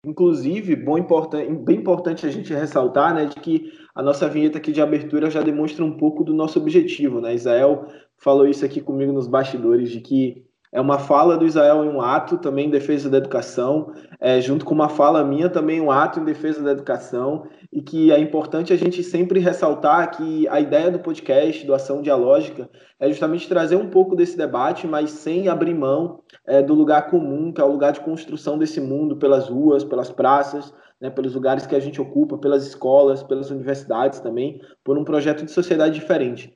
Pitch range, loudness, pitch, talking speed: 140-170 Hz, -19 LUFS, 150 Hz, 200 wpm